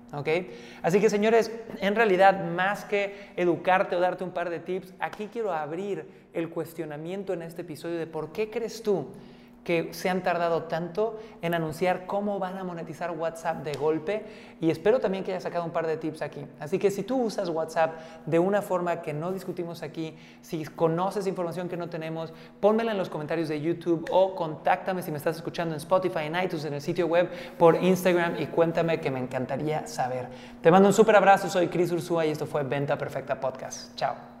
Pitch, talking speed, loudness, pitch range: 175 Hz, 200 wpm, -27 LUFS, 160-190 Hz